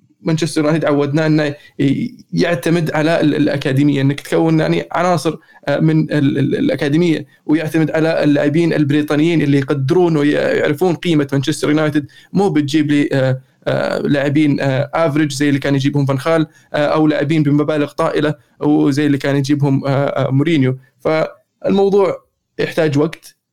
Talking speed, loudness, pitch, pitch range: 115 wpm, -15 LUFS, 150 Hz, 145-160 Hz